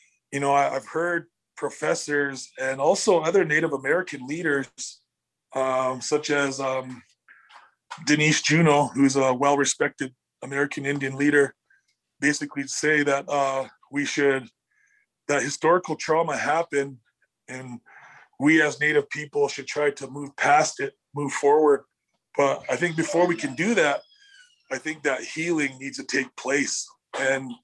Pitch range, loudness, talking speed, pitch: 135-160 Hz, -24 LUFS, 135 wpm, 145 Hz